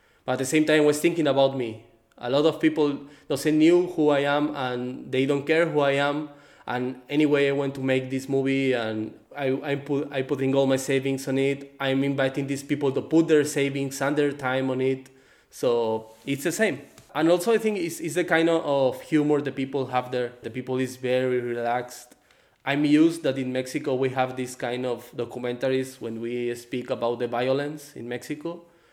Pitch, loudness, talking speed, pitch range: 135 Hz, -25 LUFS, 210 wpm, 130-150 Hz